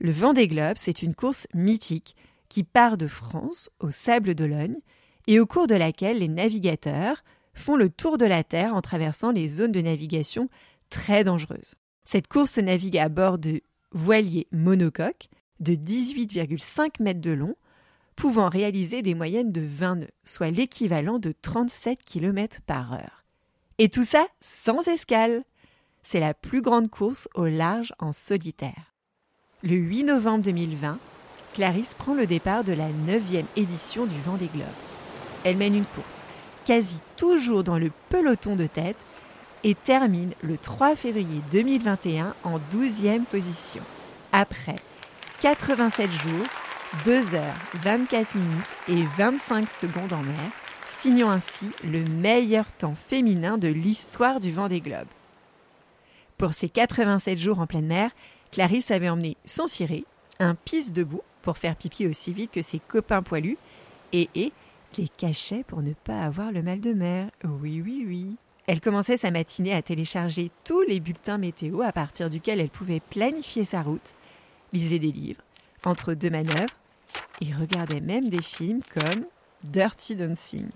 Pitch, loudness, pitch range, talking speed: 190 Hz, -25 LUFS, 165-225 Hz, 155 wpm